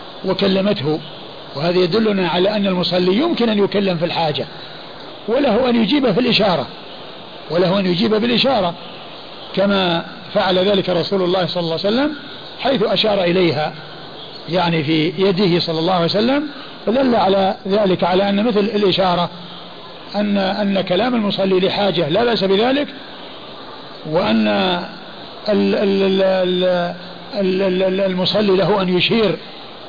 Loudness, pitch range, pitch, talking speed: -17 LUFS, 180-210 Hz, 195 Hz, 120 wpm